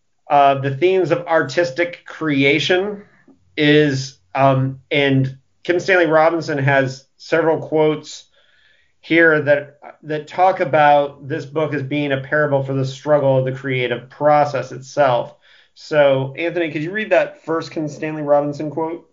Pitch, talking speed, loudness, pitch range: 150 Hz, 140 wpm, -17 LUFS, 135-160 Hz